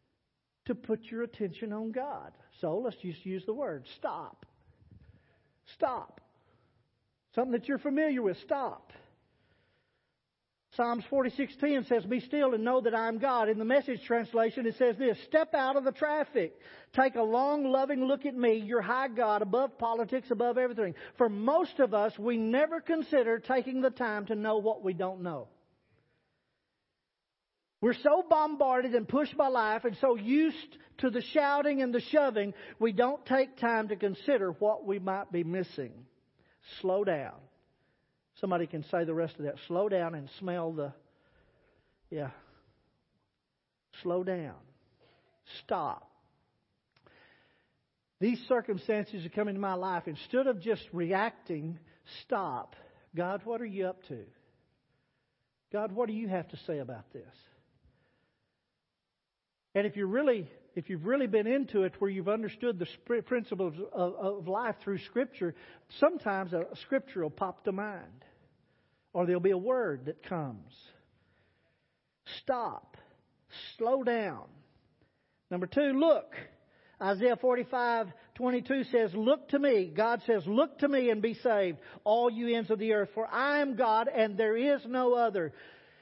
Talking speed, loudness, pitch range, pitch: 150 wpm, -31 LUFS, 190-255 Hz, 225 Hz